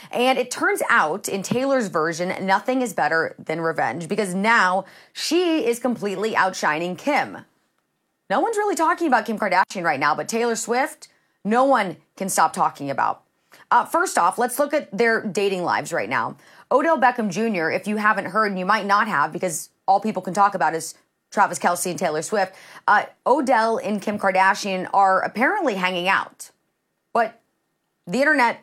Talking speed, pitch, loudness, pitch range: 175 wpm, 210 Hz, -21 LUFS, 185-245 Hz